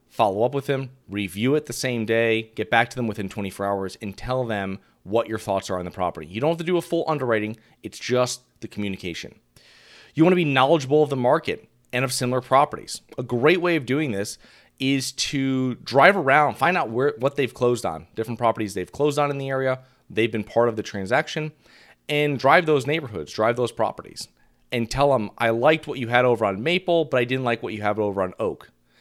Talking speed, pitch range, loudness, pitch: 225 wpm, 110-140 Hz, -23 LUFS, 125 Hz